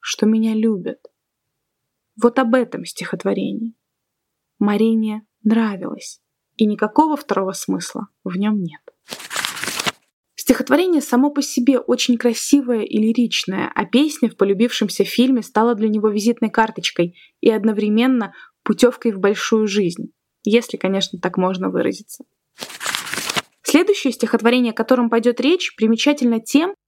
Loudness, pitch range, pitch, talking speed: -18 LUFS, 215-255 Hz, 230 Hz, 120 wpm